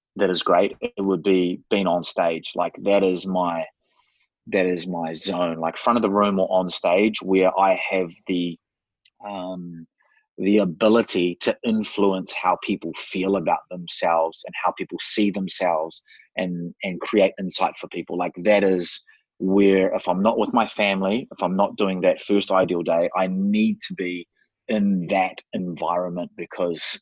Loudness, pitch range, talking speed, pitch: -22 LUFS, 90-100 Hz, 170 wpm, 95 Hz